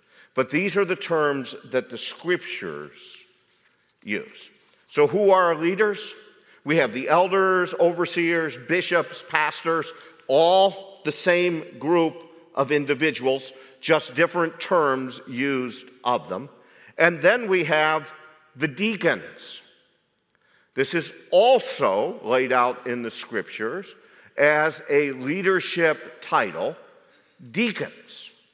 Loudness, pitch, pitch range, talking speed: -23 LUFS, 165 Hz, 145-190 Hz, 110 wpm